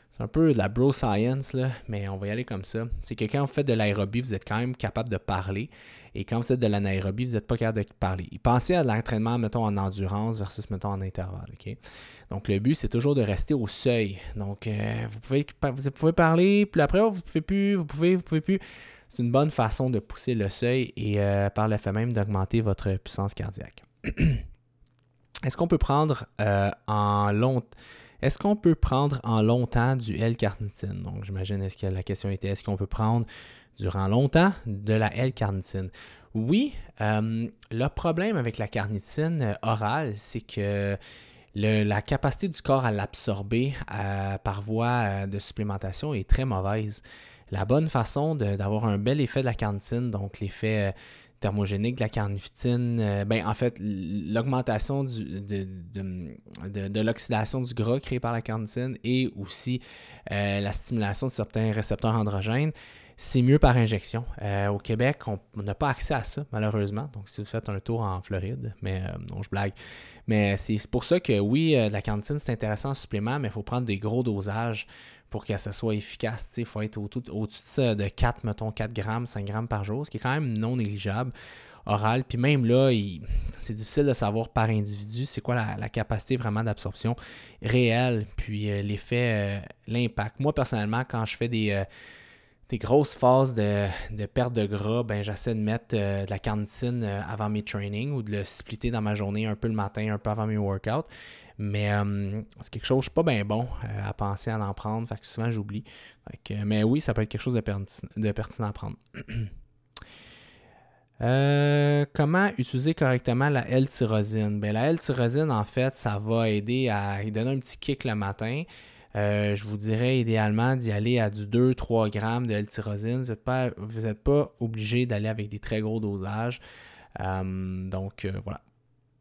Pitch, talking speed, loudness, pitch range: 110 Hz, 200 wpm, -27 LUFS, 105-125 Hz